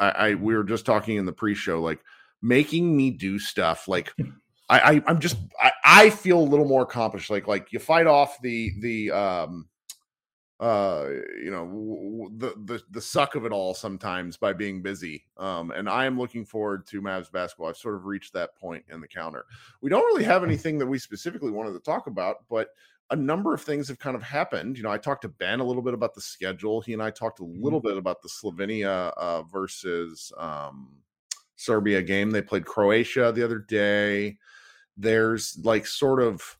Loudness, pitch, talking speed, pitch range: -24 LUFS, 110 Hz, 205 wpm, 100-130 Hz